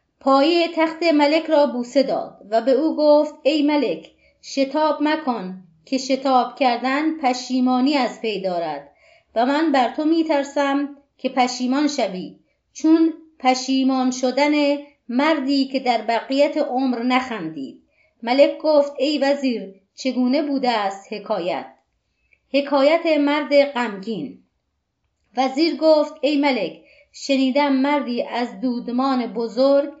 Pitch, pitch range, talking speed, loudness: 275 Hz, 250-295 Hz, 120 wpm, -20 LUFS